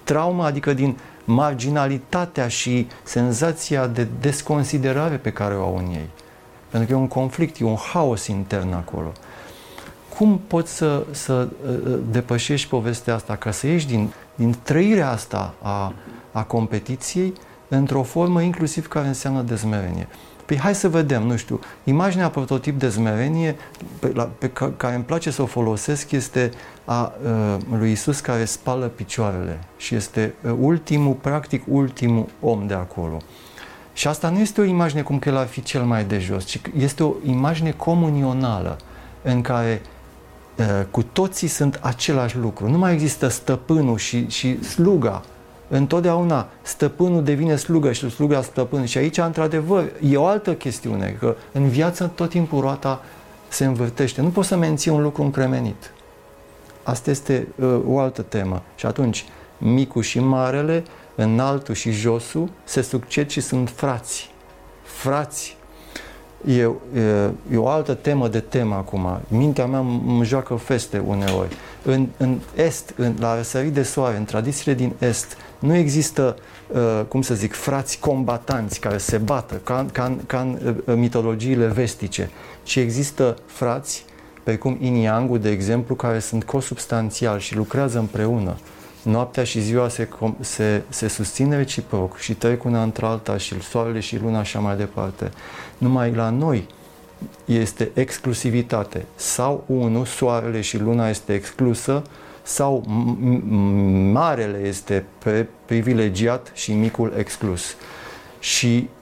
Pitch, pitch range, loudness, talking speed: 125 Hz, 110-140 Hz, -21 LUFS, 150 wpm